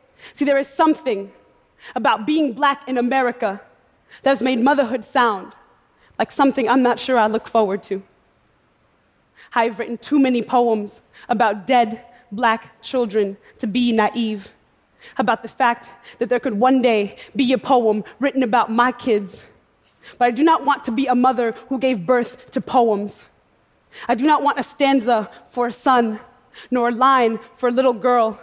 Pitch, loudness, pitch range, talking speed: 245 Hz, -19 LUFS, 225-260 Hz, 170 wpm